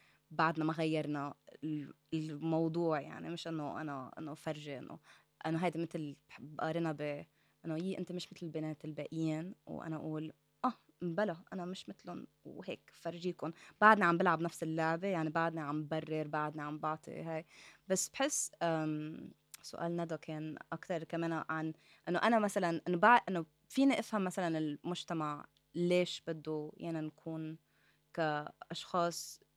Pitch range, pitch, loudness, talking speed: 155-175 Hz, 160 Hz, -37 LUFS, 135 wpm